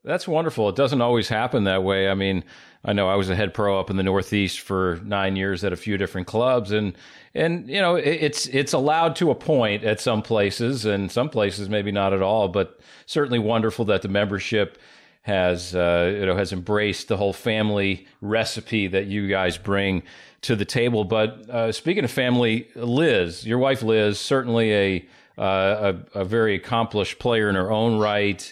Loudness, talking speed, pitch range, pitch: -22 LUFS, 195 wpm, 95-115 Hz, 105 Hz